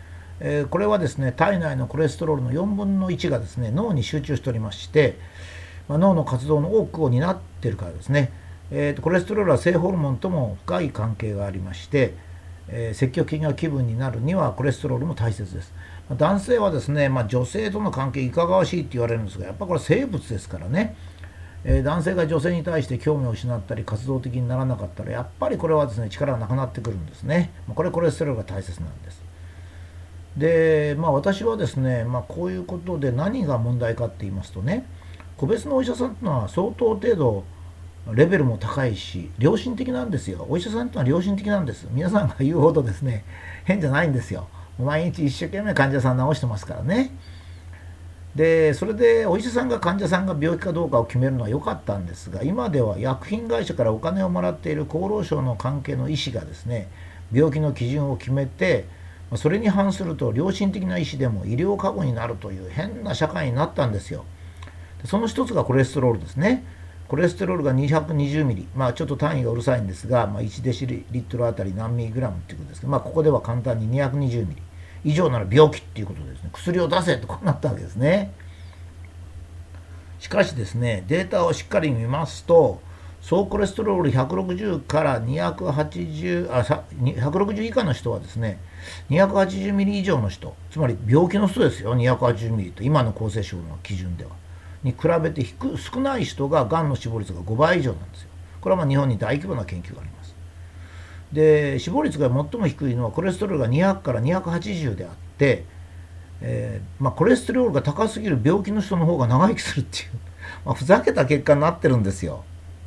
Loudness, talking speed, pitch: -23 LUFS, 400 characters per minute, 125 Hz